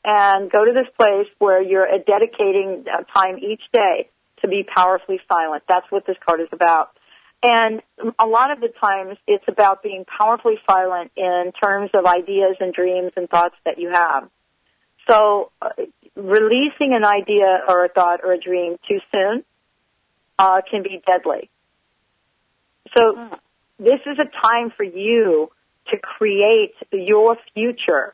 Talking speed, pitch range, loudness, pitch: 150 wpm, 185-235 Hz, -18 LUFS, 205 Hz